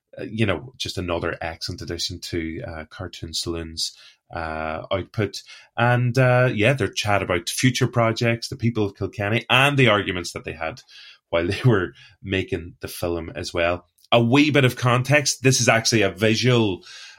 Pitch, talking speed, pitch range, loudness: 105 Hz, 170 wpm, 90-120 Hz, -21 LUFS